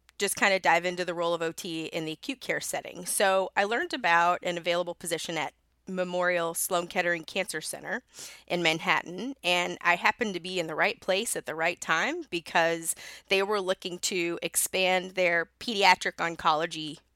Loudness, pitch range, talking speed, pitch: -28 LUFS, 170-190 Hz, 180 wpm, 175 Hz